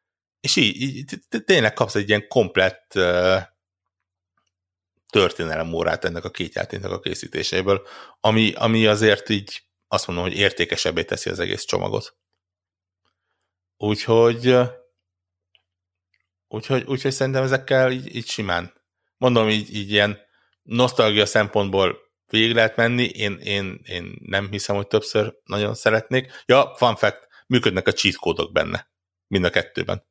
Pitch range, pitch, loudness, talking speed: 90-115 Hz, 100 Hz, -21 LUFS, 130 wpm